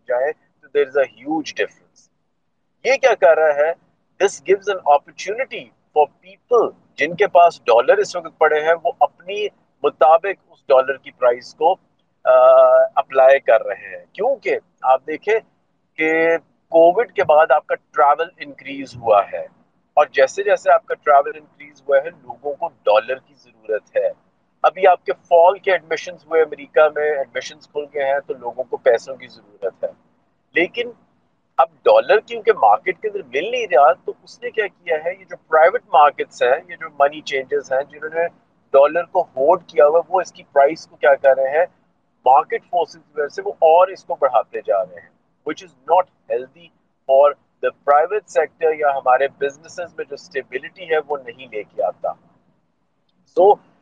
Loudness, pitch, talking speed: -17 LUFS, 170 Hz, 135 wpm